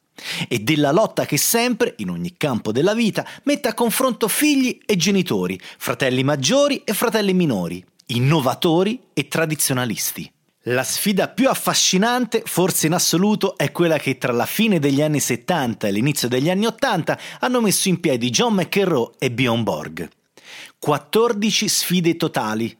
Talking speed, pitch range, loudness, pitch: 150 wpm, 135-215 Hz, -19 LUFS, 175 Hz